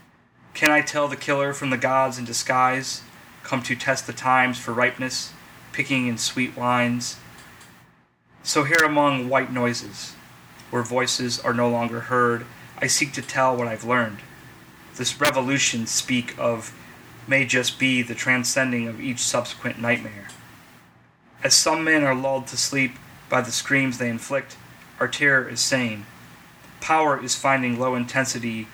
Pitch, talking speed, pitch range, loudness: 125 Hz, 150 wpm, 120-135 Hz, -22 LUFS